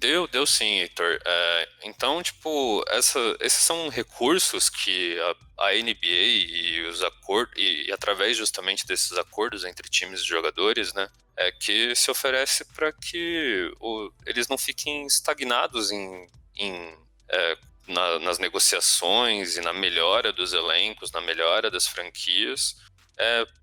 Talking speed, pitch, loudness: 140 wpm, 155 Hz, -23 LUFS